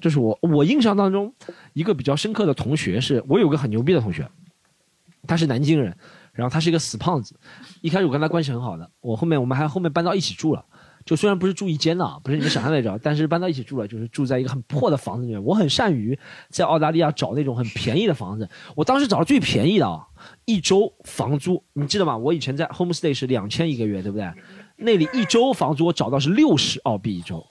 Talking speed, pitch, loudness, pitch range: 390 characters per minute, 155 Hz, -21 LUFS, 130-175 Hz